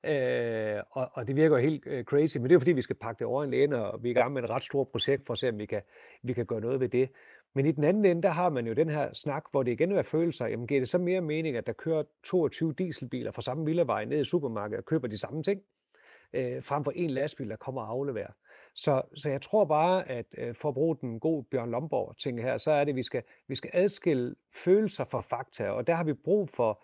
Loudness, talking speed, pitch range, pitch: -30 LUFS, 275 wpm, 125-165 Hz, 145 Hz